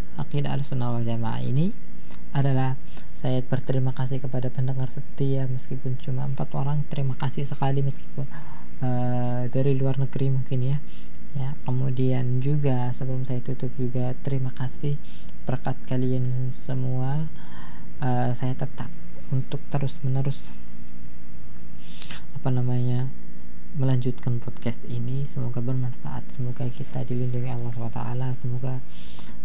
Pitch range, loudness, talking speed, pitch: 125-135 Hz, -28 LUFS, 110 wpm, 130 Hz